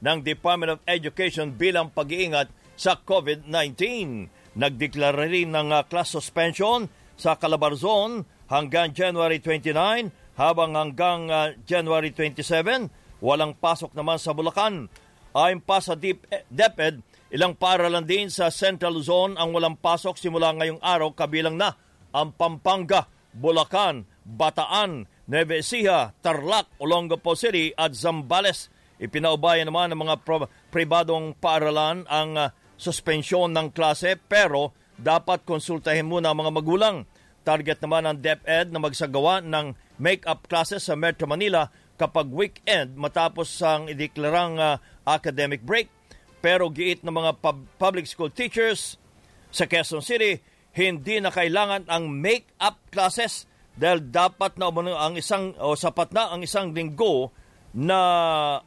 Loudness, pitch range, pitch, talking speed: -24 LUFS, 155-180 Hz, 165 Hz, 135 wpm